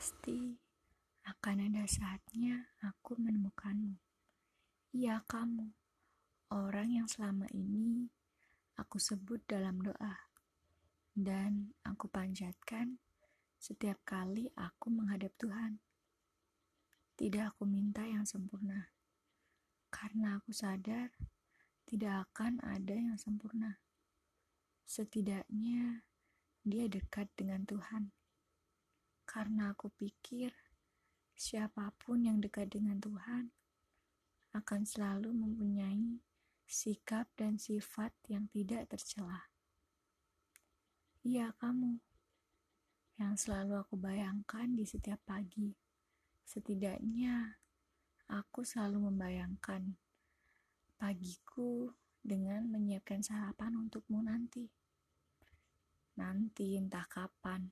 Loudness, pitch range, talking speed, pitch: -41 LUFS, 200-225 Hz, 85 wpm, 210 Hz